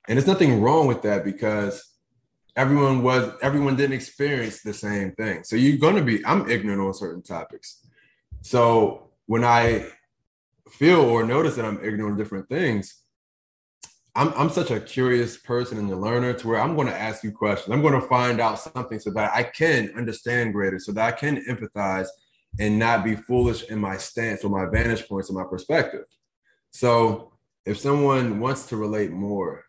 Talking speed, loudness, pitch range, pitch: 185 wpm, -23 LUFS, 105-125 Hz, 115 Hz